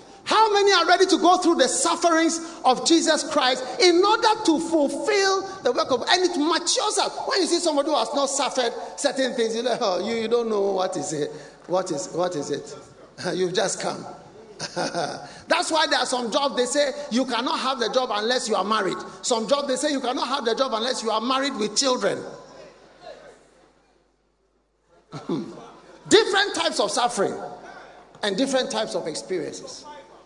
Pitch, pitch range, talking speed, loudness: 270 Hz, 230-330 Hz, 180 wpm, -22 LUFS